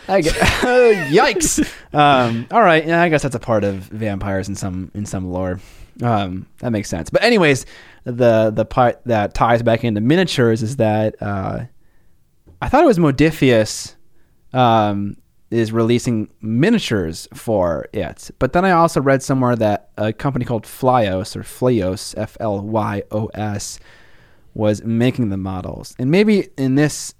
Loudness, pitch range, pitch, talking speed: -17 LUFS, 105-130 Hz, 110 Hz, 150 wpm